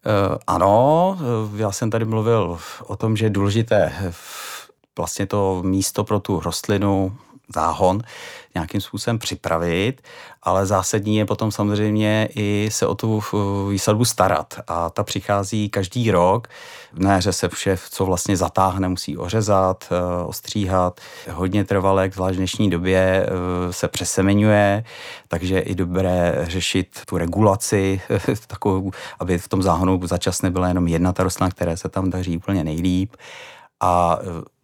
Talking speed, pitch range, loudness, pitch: 135 wpm, 90-105 Hz, -20 LUFS, 95 Hz